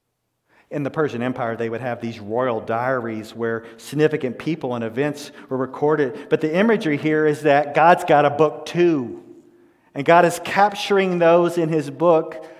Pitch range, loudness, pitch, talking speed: 125-170 Hz, -20 LUFS, 150 Hz, 170 wpm